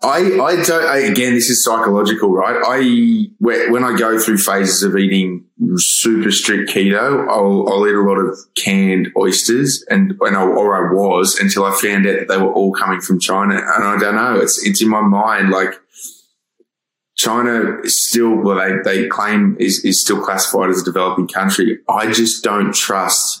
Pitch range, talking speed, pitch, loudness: 95-115 Hz, 190 wpm, 100 Hz, -14 LUFS